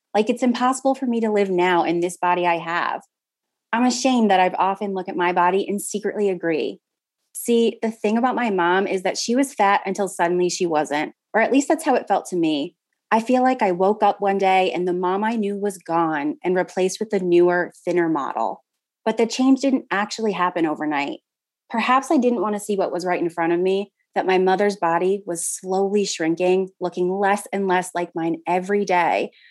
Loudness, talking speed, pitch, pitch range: -21 LUFS, 215 wpm, 195 Hz, 180-225 Hz